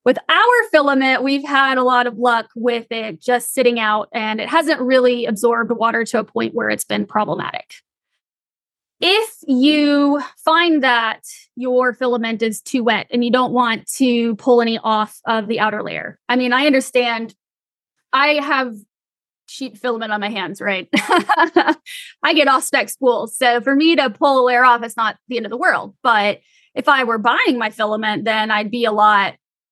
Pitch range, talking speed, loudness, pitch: 225-275 Hz, 185 wpm, -16 LUFS, 245 Hz